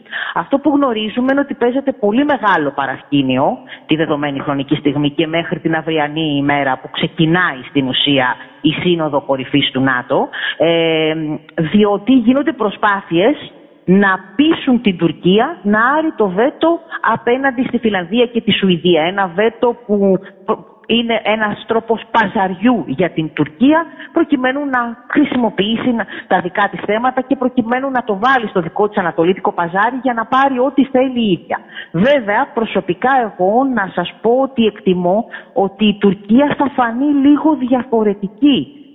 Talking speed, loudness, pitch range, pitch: 145 wpm, -15 LUFS, 170-255 Hz, 210 Hz